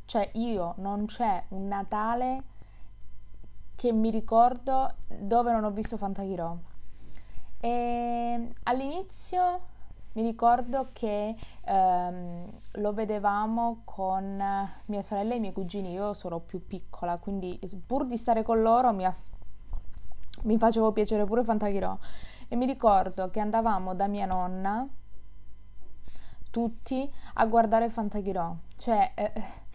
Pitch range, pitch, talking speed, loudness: 180-230 Hz, 210 Hz, 120 wpm, -29 LUFS